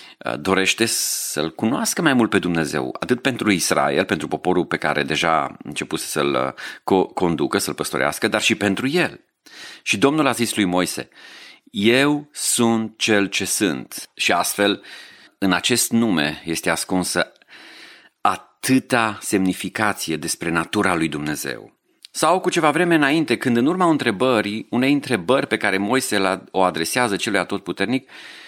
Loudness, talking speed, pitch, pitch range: -20 LUFS, 140 wpm, 105 Hz, 90-120 Hz